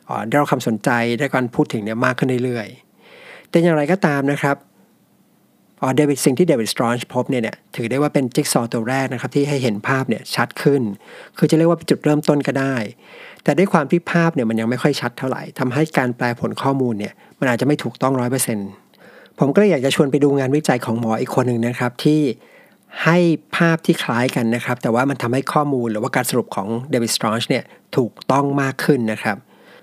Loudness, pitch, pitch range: -19 LUFS, 135 Hz, 120-150 Hz